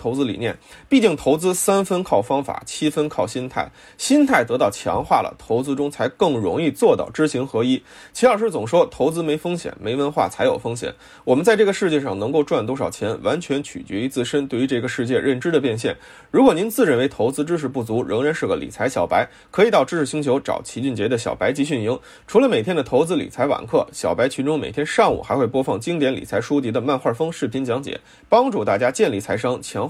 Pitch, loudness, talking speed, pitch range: 145 Hz, -20 LUFS, 340 characters per minute, 130-170 Hz